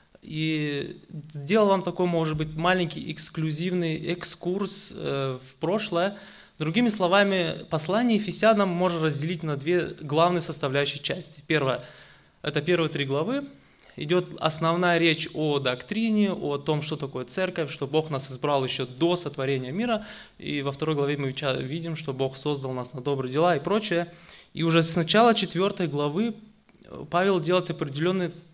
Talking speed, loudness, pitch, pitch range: 145 wpm, -26 LUFS, 165 Hz, 145-185 Hz